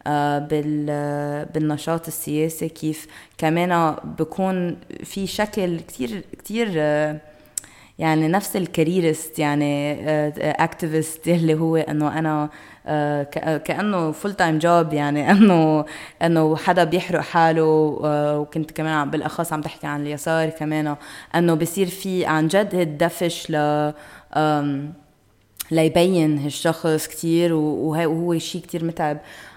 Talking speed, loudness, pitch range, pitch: 100 wpm, -21 LUFS, 150-170 Hz, 155 Hz